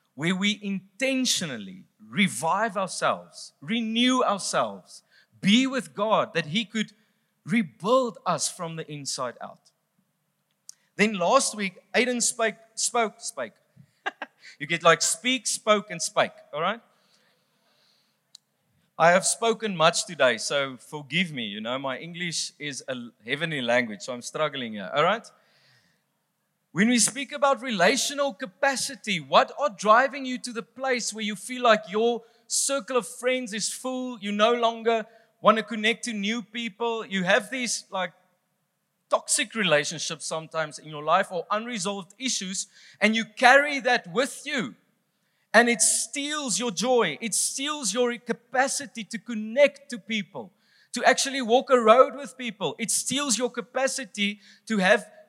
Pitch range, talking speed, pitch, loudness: 185-245 Hz, 145 wpm, 220 Hz, -25 LUFS